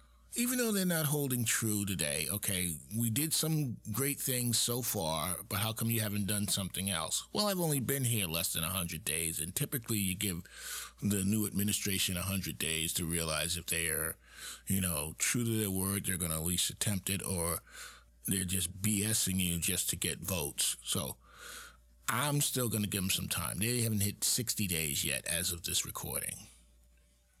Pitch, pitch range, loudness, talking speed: 95 Hz, 85-115 Hz, -33 LUFS, 195 wpm